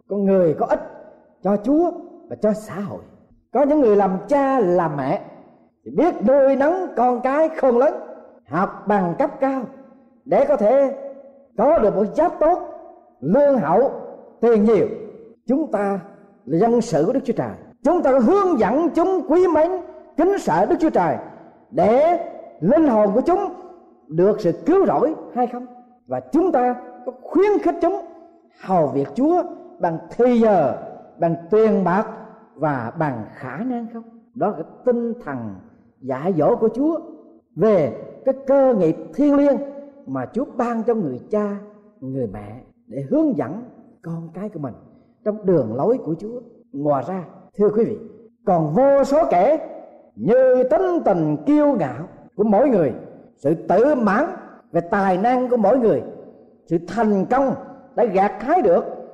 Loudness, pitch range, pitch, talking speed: -19 LUFS, 205-300 Hz, 250 Hz, 165 wpm